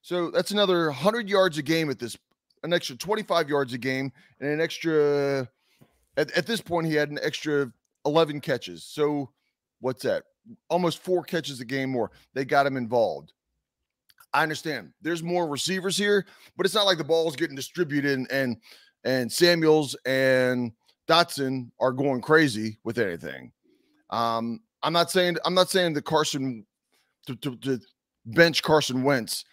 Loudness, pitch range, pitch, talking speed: -25 LUFS, 130-175 Hz, 150 Hz, 165 wpm